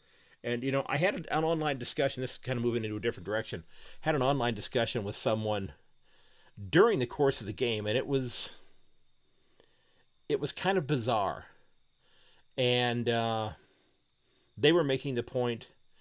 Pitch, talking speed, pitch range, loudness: 120 Hz, 165 wpm, 110-135 Hz, -31 LUFS